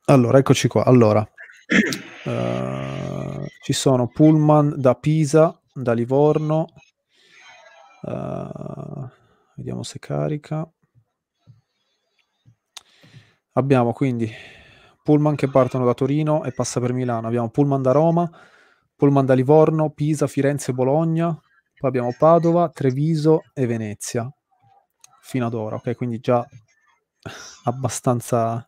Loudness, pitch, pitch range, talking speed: -20 LUFS, 130 Hz, 120-150 Hz, 105 wpm